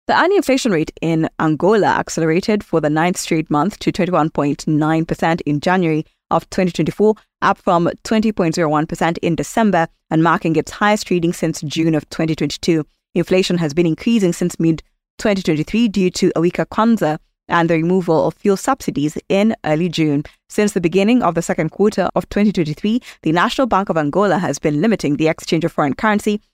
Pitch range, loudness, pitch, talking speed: 160-195 Hz, -17 LUFS, 170 Hz, 165 wpm